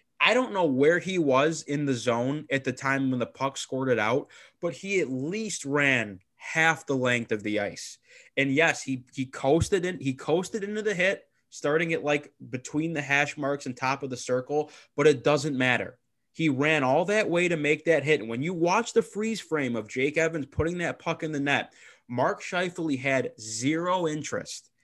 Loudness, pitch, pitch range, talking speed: -27 LUFS, 145 Hz, 130-165 Hz, 210 wpm